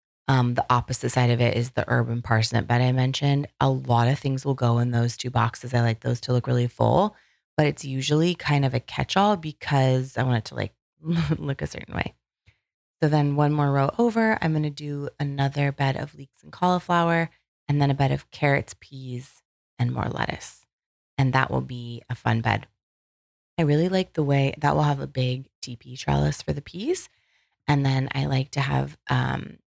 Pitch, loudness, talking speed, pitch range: 135 Hz, -24 LUFS, 205 wpm, 120-145 Hz